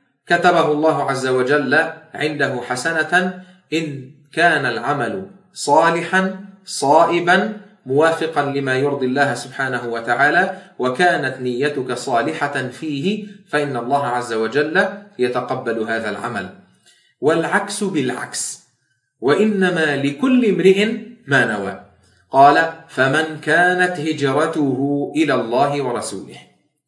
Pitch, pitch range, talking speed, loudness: 155 Hz, 140-190 Hz, 95 wpm, -18 LUFS